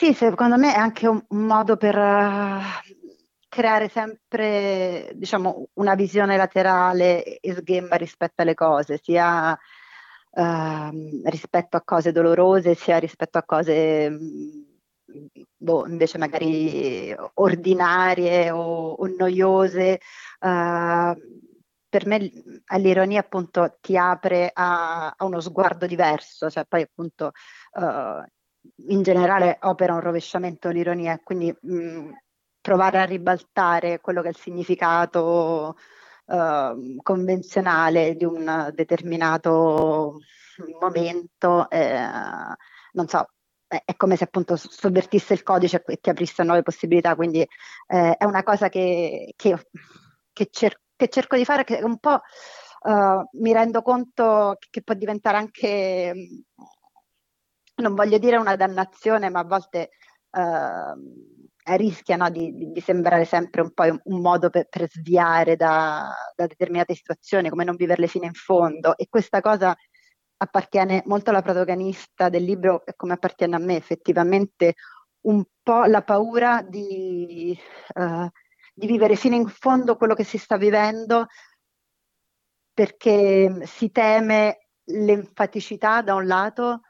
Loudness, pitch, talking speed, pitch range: -21 LUFS, 185 Hz, 130 wpm, 170-210 Hz